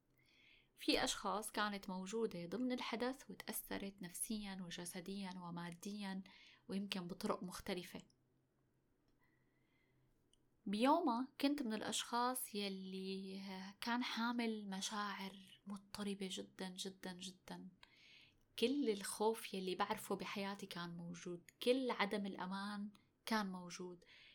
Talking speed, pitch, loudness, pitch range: 90 wpm, 200 Hz, -43 LUFS, 185-220 Hz